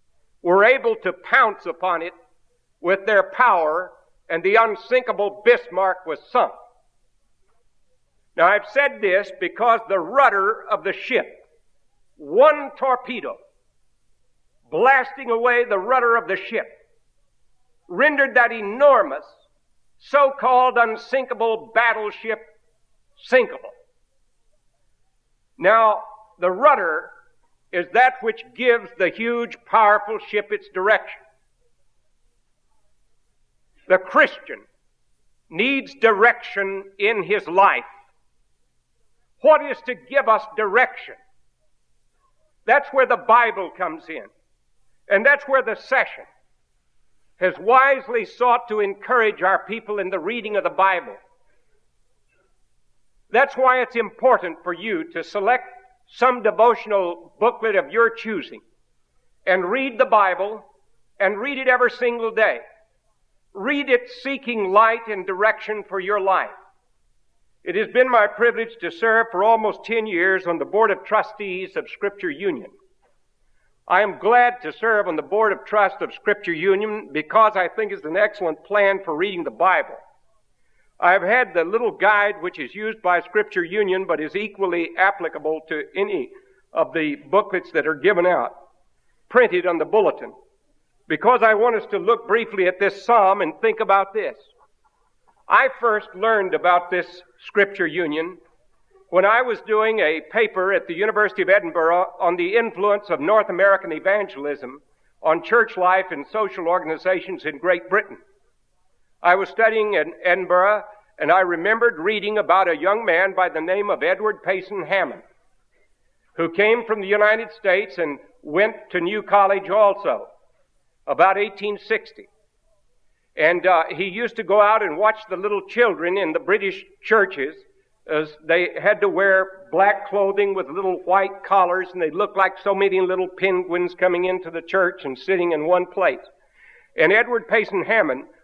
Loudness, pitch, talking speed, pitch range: -19 LUFS, 210 Hz, 140 wpm, 185-240 Hz